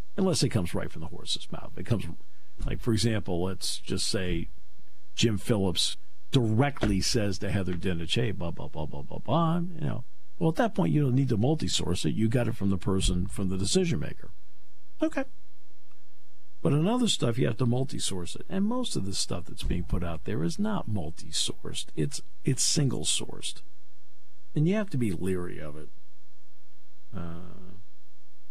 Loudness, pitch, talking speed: -29 LUFS, 95 Hz, 190 wpm